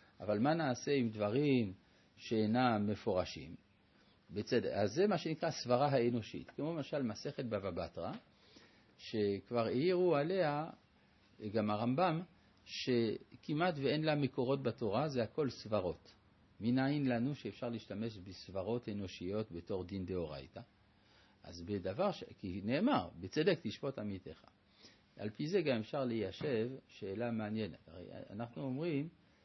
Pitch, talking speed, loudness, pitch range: 115 Hz, 120 wpm, -38 LUFS, 100-135 Hz